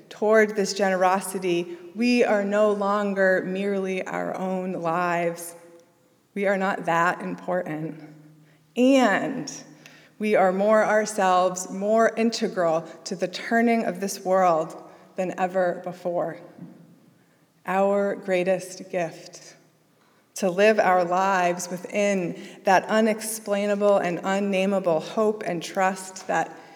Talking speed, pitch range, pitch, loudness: 110 wpm, 175-205 Hz, 190 Hz, -23 LUFS